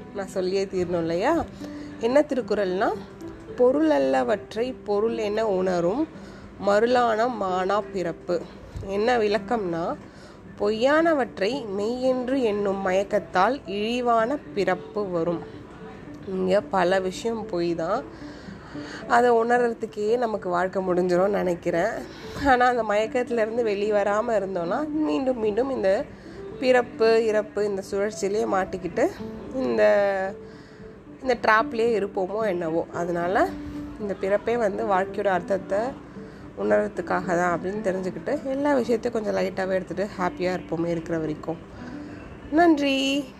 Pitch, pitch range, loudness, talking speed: 205 Hz, 185-235 Hz, -24 LUFS, 105 wpm